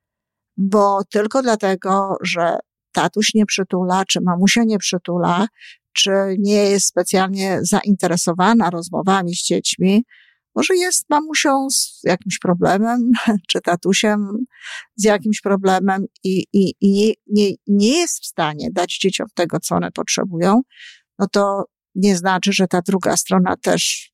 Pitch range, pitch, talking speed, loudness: 185-210 Hz, 195 Hz, 135 wpm, -17 LUFS